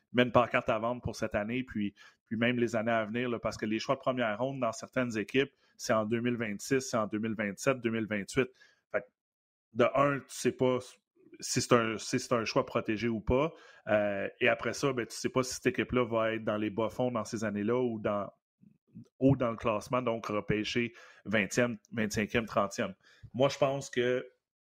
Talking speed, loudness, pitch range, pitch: 205 wpm, -32 LUFS, 110-125 Hz, 115 Hz